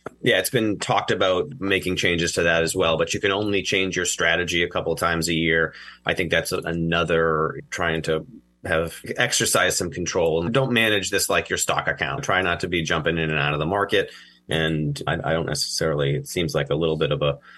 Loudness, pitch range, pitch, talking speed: -22 LUFS, 80-90 Hz, 85 Hz, 225 wpm